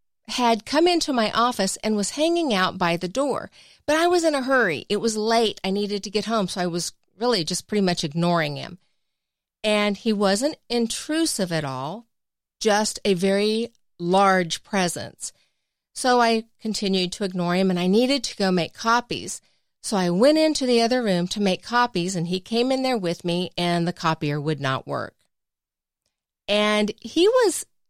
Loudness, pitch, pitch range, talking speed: -22 LUFS, 210 Hz, 180-240 Hz, 185 wpm